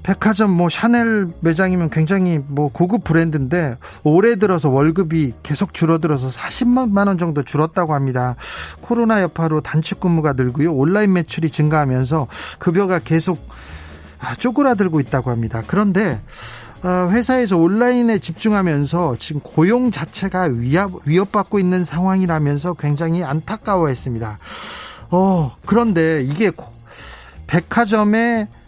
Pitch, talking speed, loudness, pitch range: 170 Hz, 305 characters per minute, -17 LUFS, 145-195 Hz